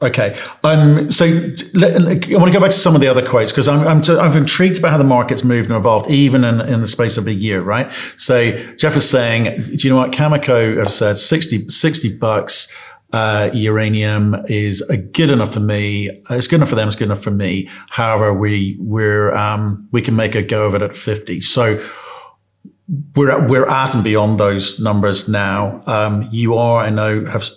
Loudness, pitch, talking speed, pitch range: -14 LUFS, 115 Hz, 205 wpm, 105-140 Hz